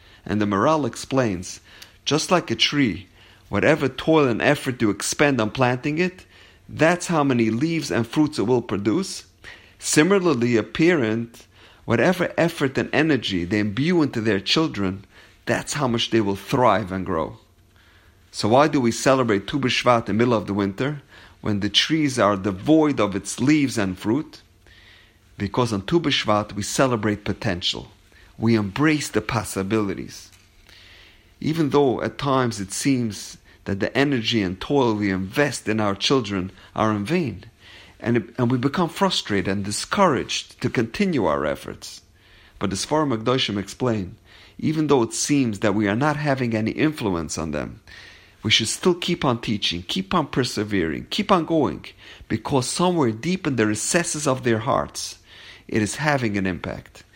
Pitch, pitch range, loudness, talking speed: 110 Hz, 100-140 Hz, -22 LUFS, 160 wpm